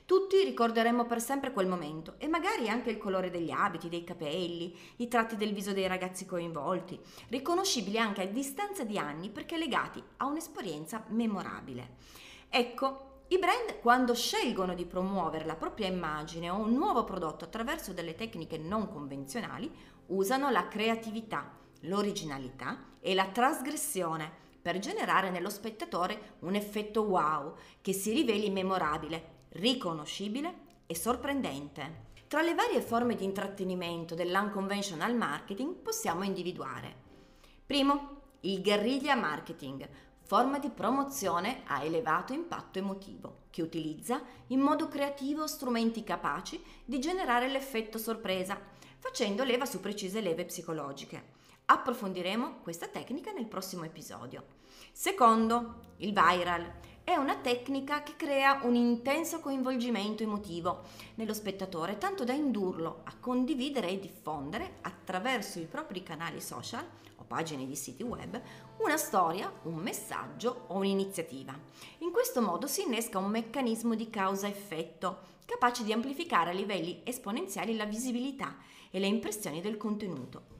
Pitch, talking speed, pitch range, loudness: 210 Hz, 130 wpm, 175-255 Hz, -33 LUFS